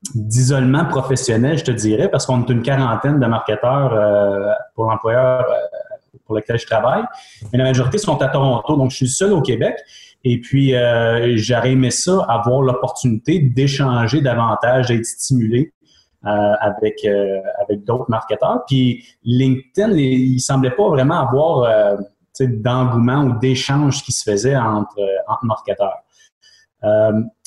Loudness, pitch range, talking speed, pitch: -17 LUFS, 115-135 Hz, 150 wpm, 125 Hz